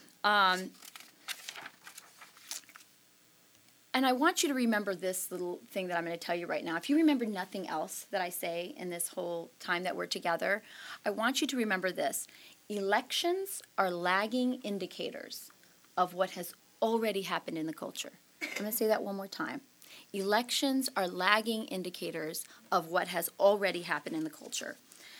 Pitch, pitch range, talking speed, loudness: 200 Hz, 180-245 Hz, 170 wpm, -33 LUFS